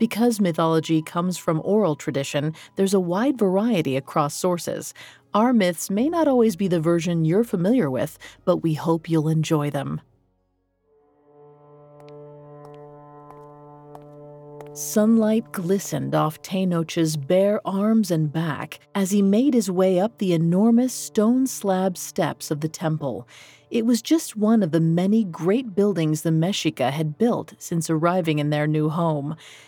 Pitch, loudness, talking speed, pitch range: 165 Hz, -22 LUFS, 140 wpm, 145-200 Hz